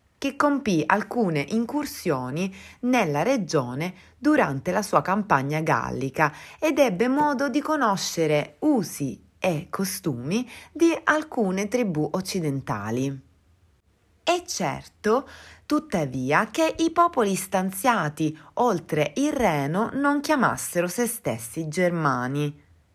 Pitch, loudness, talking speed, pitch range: 190 Hz, -24 LUFS, 100 wpm, 150-250 Hz